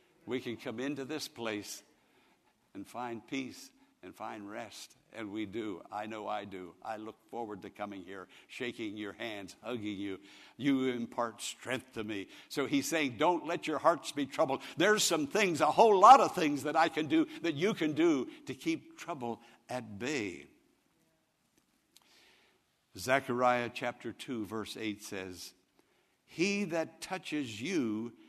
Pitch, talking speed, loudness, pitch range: 125 Hz, 160 wpm, -33 LUFS, 110-165 Hz